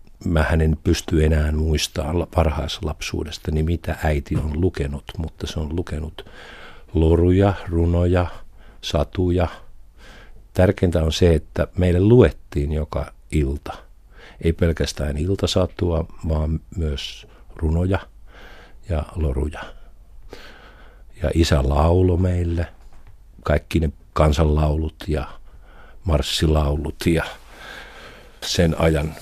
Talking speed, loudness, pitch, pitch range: 100 wpm, -21 LUFS, 80 Hz, 75-90 Hz